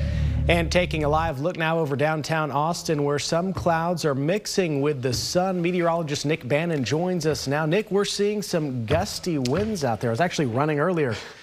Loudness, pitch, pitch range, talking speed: -24 LUFS, 160 Hz, 145-175 Hz, 190 wpm